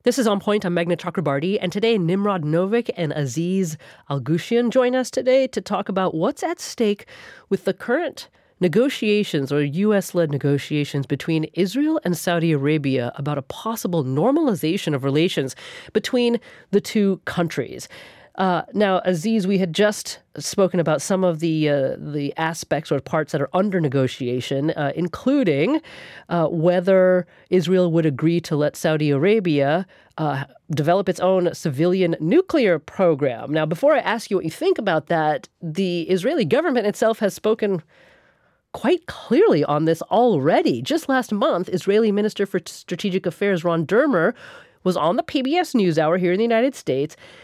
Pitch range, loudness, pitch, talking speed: 155-210 Hz, -21 LUFS, 180 Hz, 160 wpm